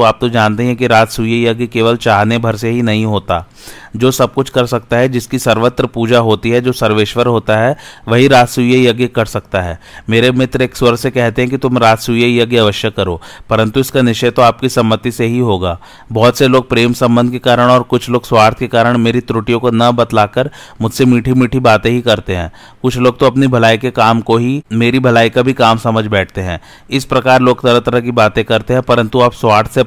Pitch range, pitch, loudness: 115-125 Hz, 120 Hz, -12 LUFS